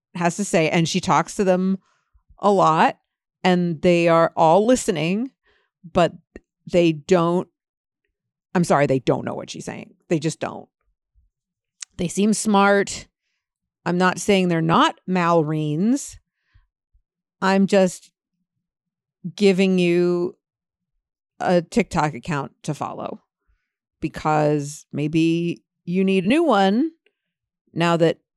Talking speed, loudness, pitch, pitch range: 120 wpm, -20 LUFS, 180 Hz, 165-195 Hz